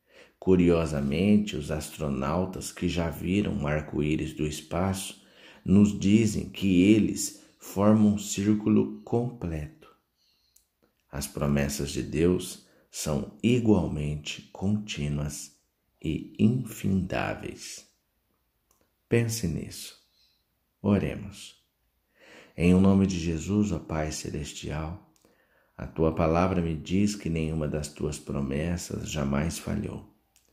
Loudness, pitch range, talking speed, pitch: -27 LUFS, 75-100 Hz, 100 wpm, 85 Hz